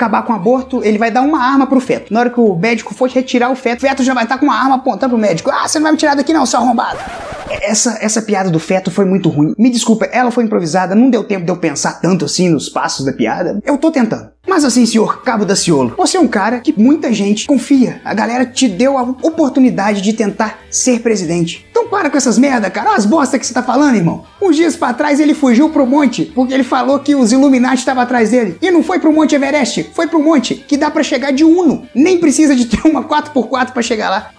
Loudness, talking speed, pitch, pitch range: -12 LUFS, 260 wpm, 255 Hz, 225-285 Hz